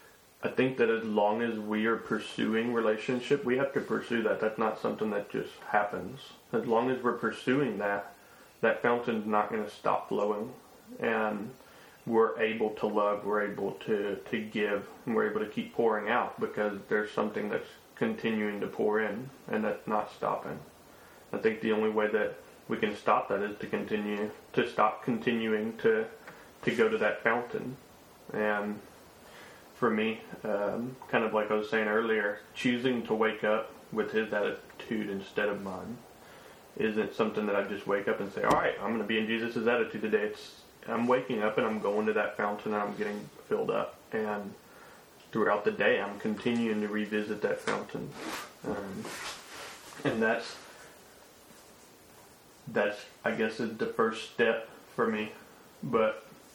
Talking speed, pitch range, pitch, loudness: 175 wpm, 105-115 Hz, 110 Hz, -31 LUFS